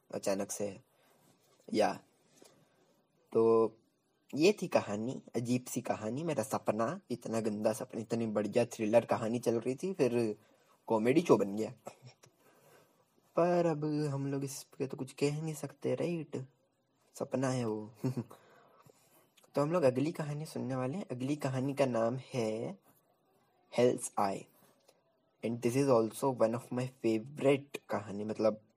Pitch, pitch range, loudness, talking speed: 130 Hz, 115-140 Hz, -34 LUFS, 140 wpm